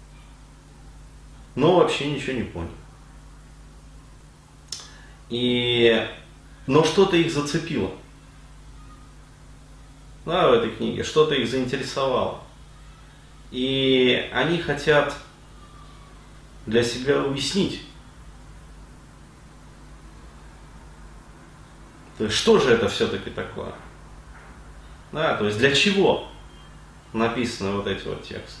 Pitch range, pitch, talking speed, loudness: 85-140 Hz, 120 Hz, 85 wpm, -22 LUFS